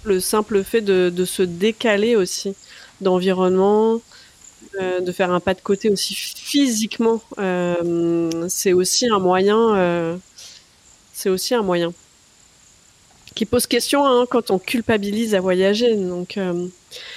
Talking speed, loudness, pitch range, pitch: 130 wpm, -19 LUFS, 185-225 Hz, 195 Hz